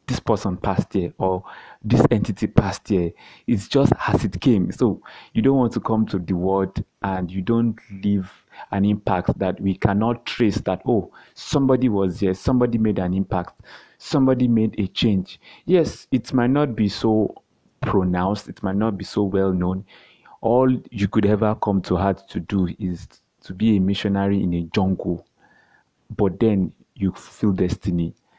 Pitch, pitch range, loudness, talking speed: 100 Hz, 95-115 Hz, -22 LUFS, 175 wpm